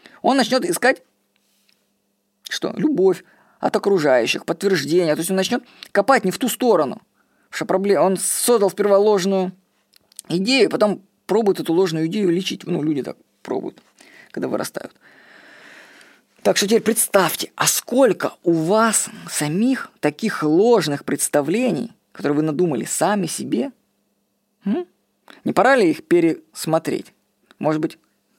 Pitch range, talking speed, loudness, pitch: 170-240 Hz, 130 wpm, -19 LUFS, 195 Hz